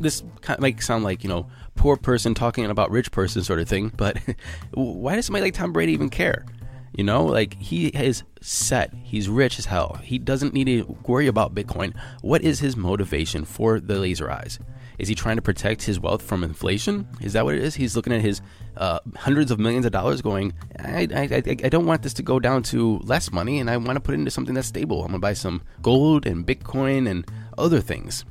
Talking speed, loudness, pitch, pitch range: 230 wpm, -23 LUFS, 115 Hz, 100-130 Hz